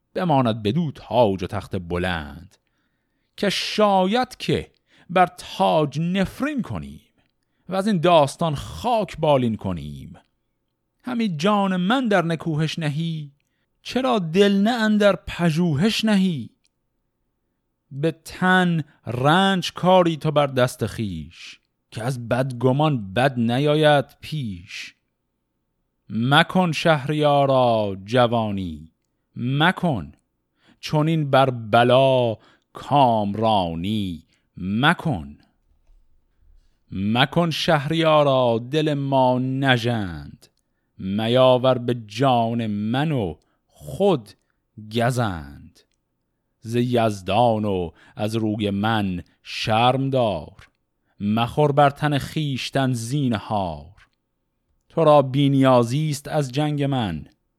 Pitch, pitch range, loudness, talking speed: 130 Hz, 105-155 Hz, -21 LUFS, 90 wpm